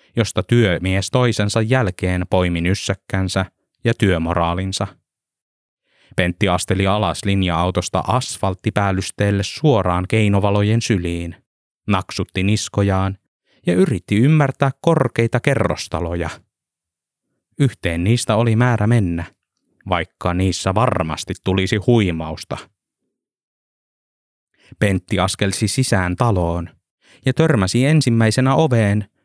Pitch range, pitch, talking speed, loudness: 90-115 Hz, 100 Hz, 85 wpm, -18 LUFS